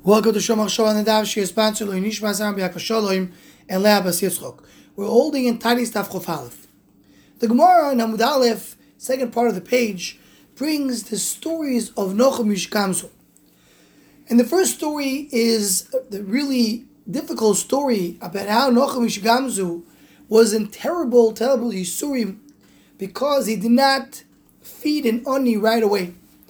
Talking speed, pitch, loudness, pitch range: 130 wpm, 225 Hz, -20 LUFS, 200-255 Hz